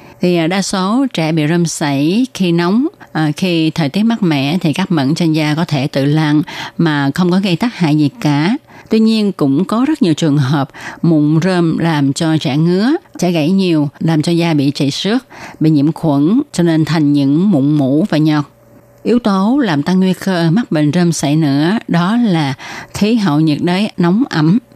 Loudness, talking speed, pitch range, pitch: -13 LUFS, 205 wpm, 150-190 Hz, 165 Hz